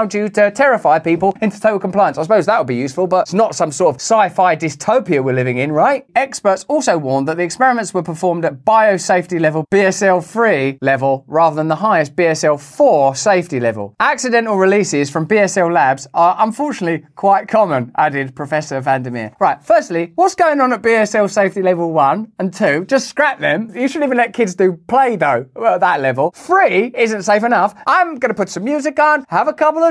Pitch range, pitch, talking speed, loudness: 160-235 Hz, 195 Hz, 205 wpm, -15 LUFS